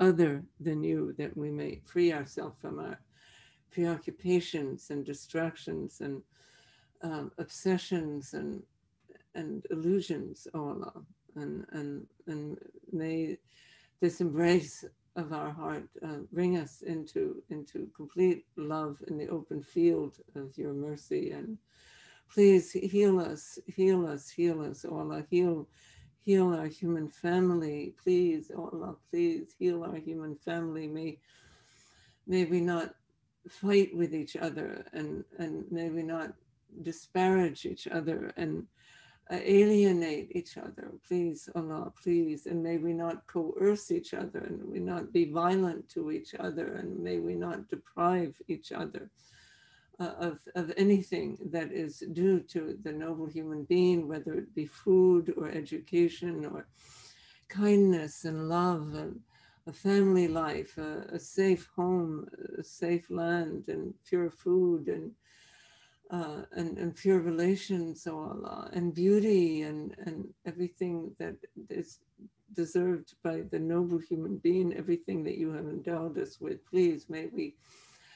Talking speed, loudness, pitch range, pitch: 140 wpm, -32 LUFS, 160-185 Hz, 170 Hz